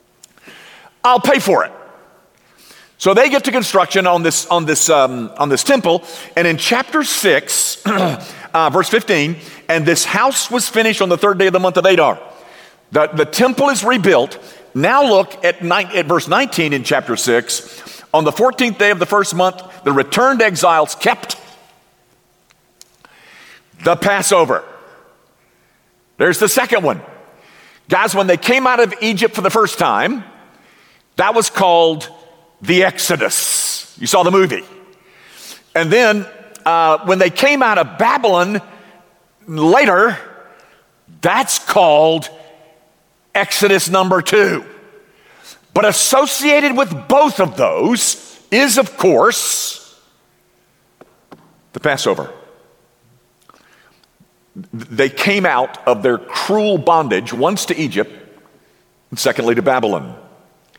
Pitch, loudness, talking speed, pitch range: 190 Hz, -14 LUFS, 130 wpm, 165-245 Hz